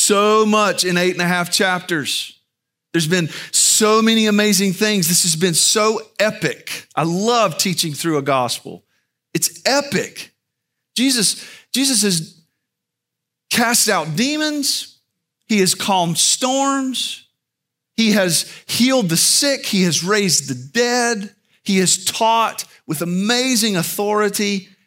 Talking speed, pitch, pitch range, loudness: 130 wpm, 200 Hz, 175-225 Hz, -16 LUFS